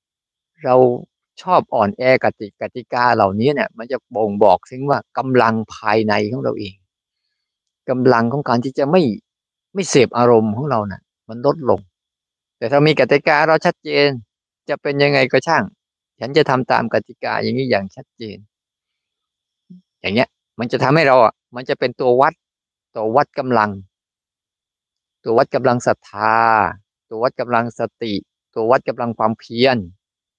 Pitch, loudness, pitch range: 120 Hz, -17 LUFS, 105-135 Hz